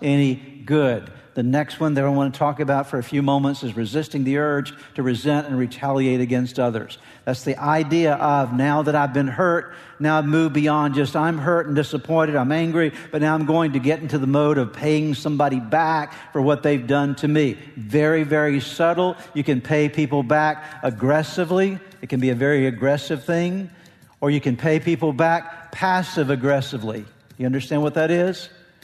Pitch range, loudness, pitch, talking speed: 140-155 Hz, -21 LUFS, 150 Hz, 195 wpm